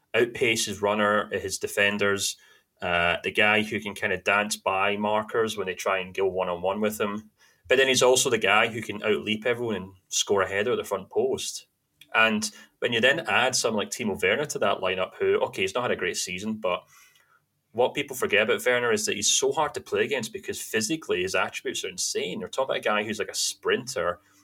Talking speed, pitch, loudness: 220 wpm, 110 Hz, -25 LUFS